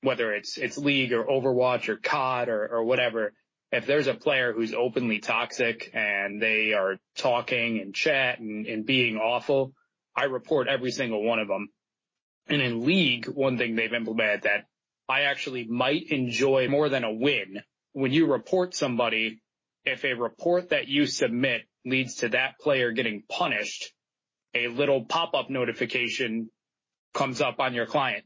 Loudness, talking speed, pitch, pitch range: -26 LUFS, 160 wpm, 125 Hz, 115-135 Hz